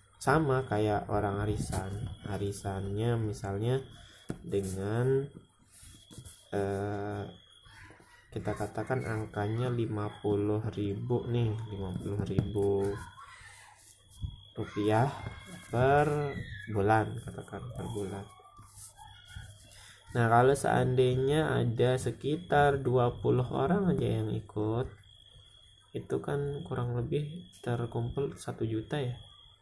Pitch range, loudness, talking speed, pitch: 100-120 Hz, -32 LUFS, 80 wpm, 110 Hz